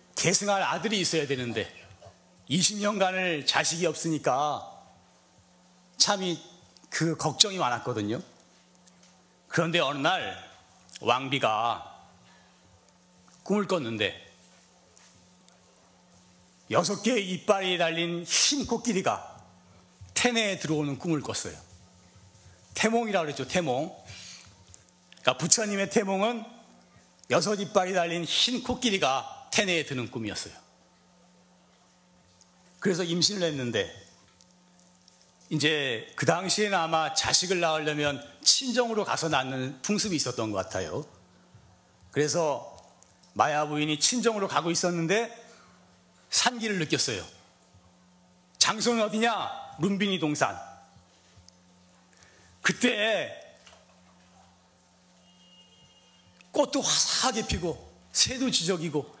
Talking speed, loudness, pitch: 215 characters per minute, -27 LUFS, 160 Hz